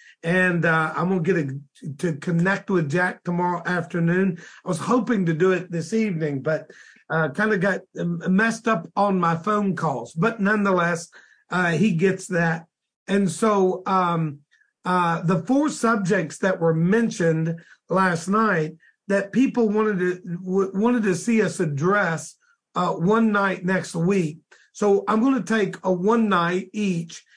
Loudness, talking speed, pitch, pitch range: -22 LUFS, 160 wpm, 185 Hz, 170-205 Hz